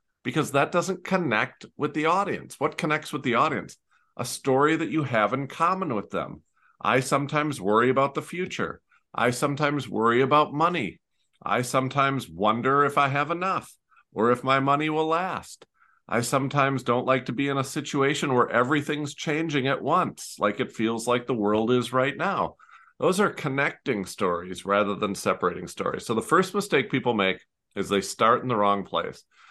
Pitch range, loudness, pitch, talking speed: 120-150 Hz, -25 LUFS, 135 Hz, 180 wpm